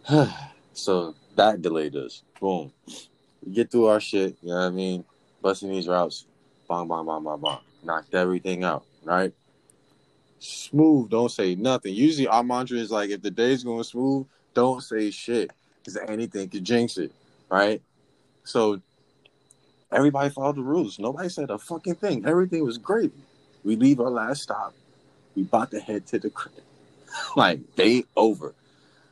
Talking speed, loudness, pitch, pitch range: 160 wpm, -25 LUFS, 115 Hz, 95-135 Hz